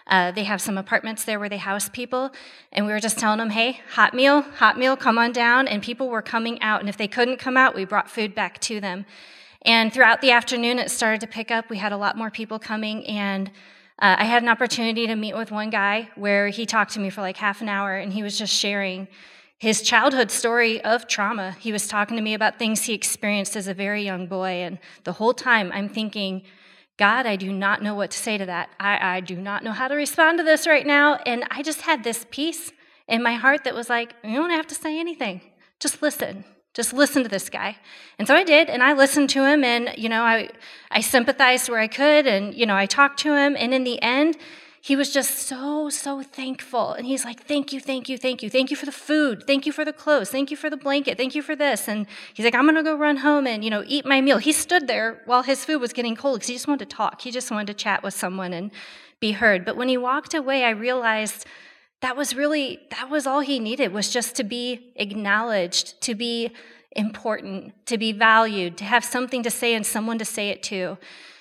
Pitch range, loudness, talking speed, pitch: 210-270 Hz, -21 LUFS, 250 wpm, 230 Hz